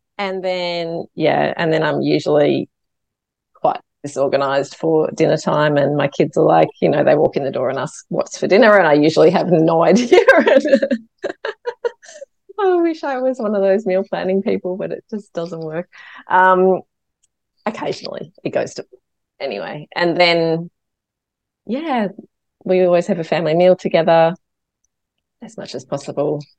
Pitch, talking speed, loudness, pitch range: 180 Hz, 160 wpm, -16 LUFS, 160-210 Hz